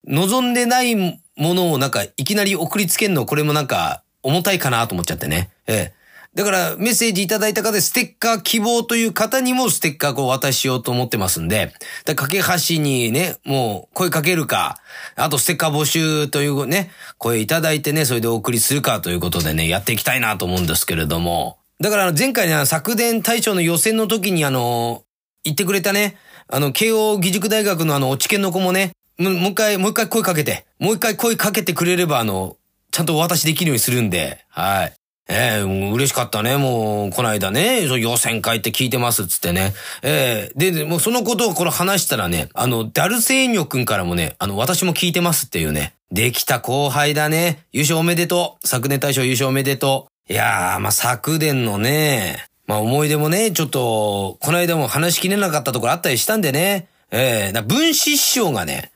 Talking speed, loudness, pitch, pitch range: 400 characters per minute, -18 LUFS, 150 Hz, 120-190 Hz